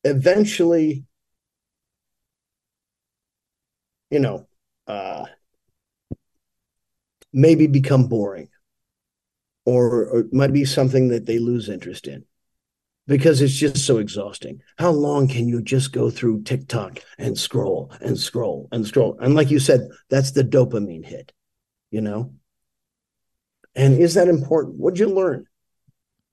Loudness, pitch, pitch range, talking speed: -19 LUFS, 135 Hz, 115-150 Hz, 125 wpm